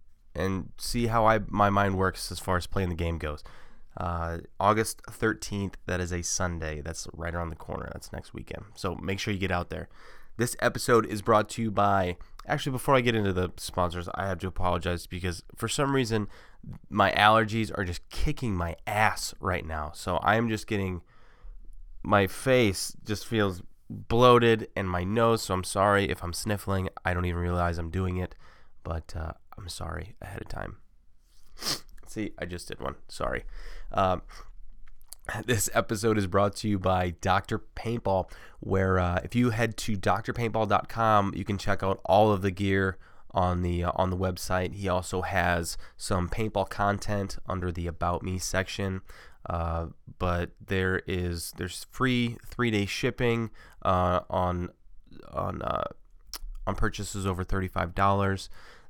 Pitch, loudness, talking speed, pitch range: 95 Hz, -28 LUFS, 170 wpm, 90-105 Hz